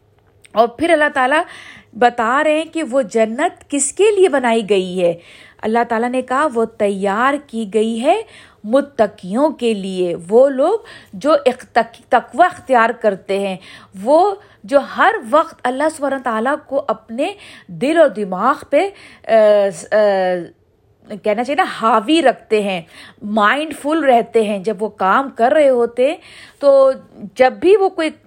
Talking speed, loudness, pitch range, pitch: 155 wpm, -16 LUFS, 210-295 Hz, 245 Hz